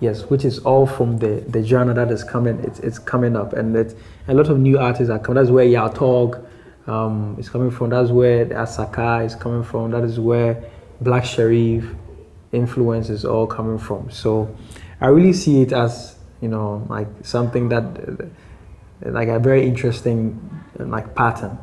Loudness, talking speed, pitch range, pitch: -19 LUFS, 180 wpm, 110-125 Hz, 120 Hz